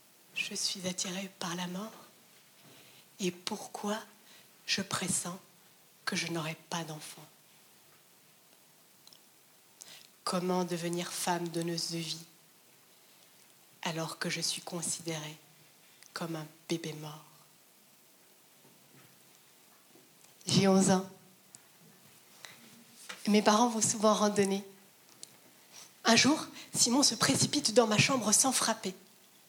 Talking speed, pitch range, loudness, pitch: 100 wpm, 170-210 Hz, -31 LUFS, 185 Hz